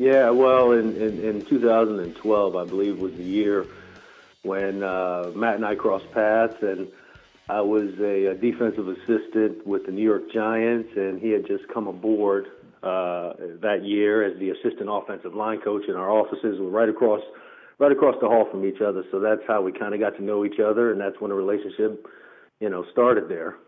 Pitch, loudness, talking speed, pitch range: 105 Hz, -23 LUFS, 200 wpm, 100-115 Hz